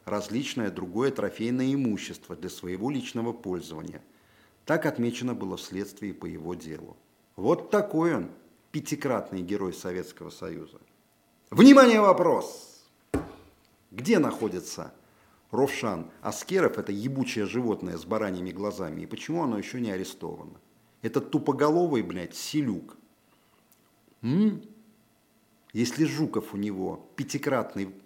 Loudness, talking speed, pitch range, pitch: -27 LUFS, 110 wpm, 95-150 Hz, 110 Hz